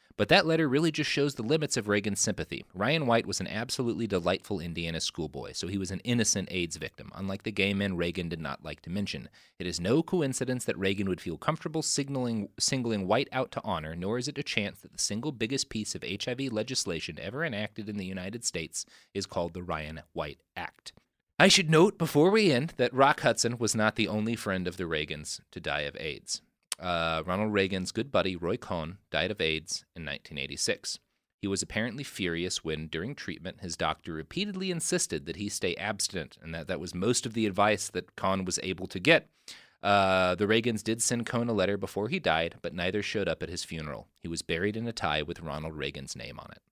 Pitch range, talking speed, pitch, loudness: 90-120 Hz, 215 wpm, 100 Hz, -30 LUFS